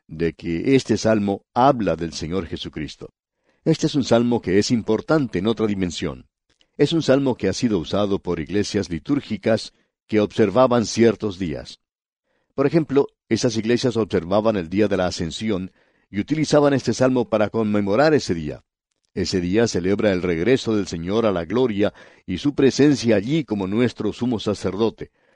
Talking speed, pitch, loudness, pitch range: 160 wpm, 110 Hz, -21 LUFS, 95-125 Hz